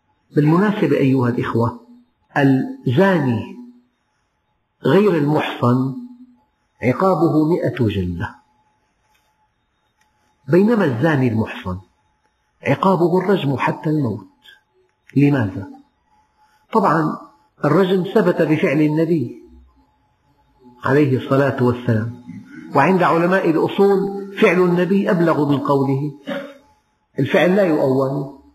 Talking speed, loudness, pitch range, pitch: 75 wpm, -17 LUFS, 125-190 Hz, 150 Hz